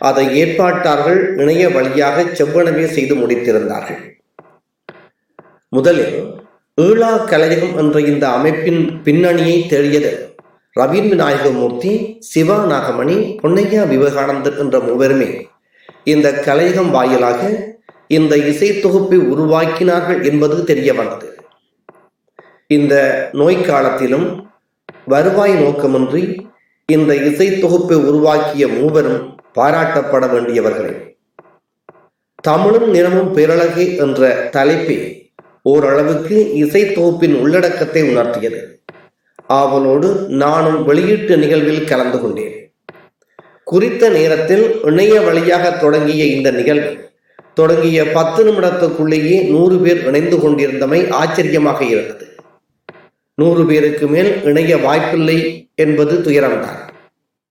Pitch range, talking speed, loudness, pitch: 145-185 Hz, 80 wpm, -13 LUFS, 160 Hz